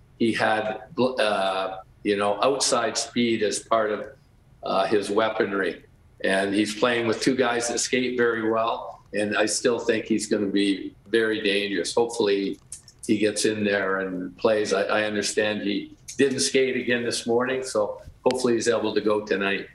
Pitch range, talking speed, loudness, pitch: 100-120 Hz, 170 wpm, -24 LUFS, 110 Hz